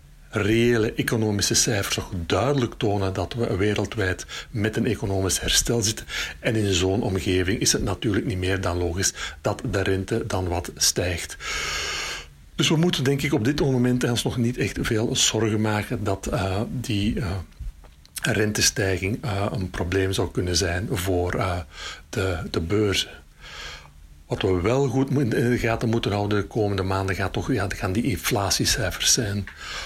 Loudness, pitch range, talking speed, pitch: -24 LUFS, 95-120 Hz, 160 wpm, 105 Hz